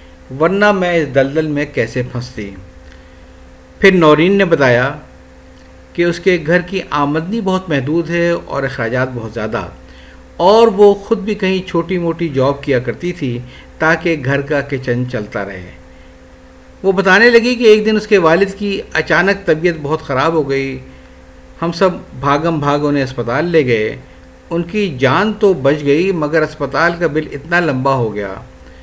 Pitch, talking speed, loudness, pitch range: 145 Hz, 165 wpm, -14 LUFS, 115-175 Hz